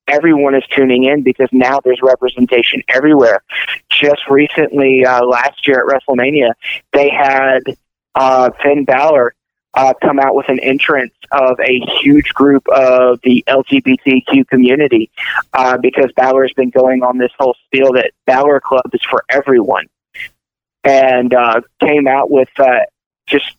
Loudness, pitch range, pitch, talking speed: -11 LUFS, 125-140 Hz, 130 Hz, 150 wpm